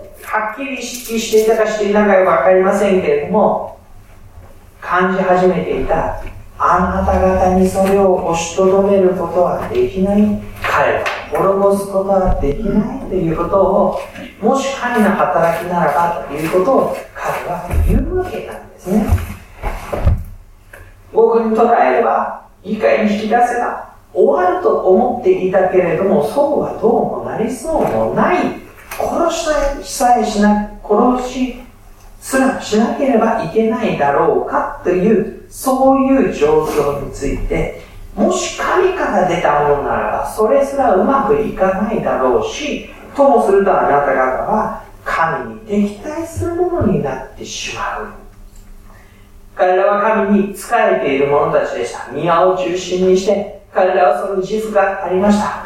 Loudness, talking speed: -15 LUFS, 285 characters per minute